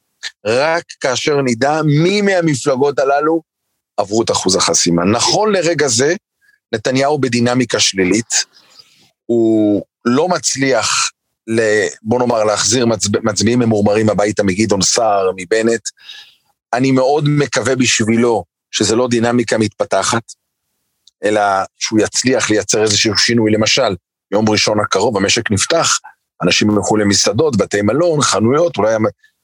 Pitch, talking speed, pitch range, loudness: 120 Hz, 110 wpm, 110-145 Hz, -14 LUFS